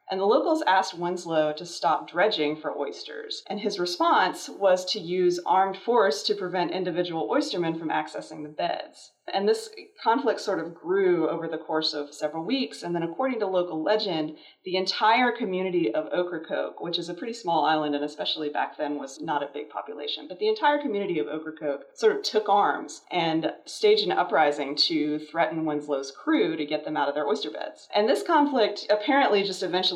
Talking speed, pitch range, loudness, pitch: 190 wpm, 155-215 Hz, -26 LUFS, 180 Hz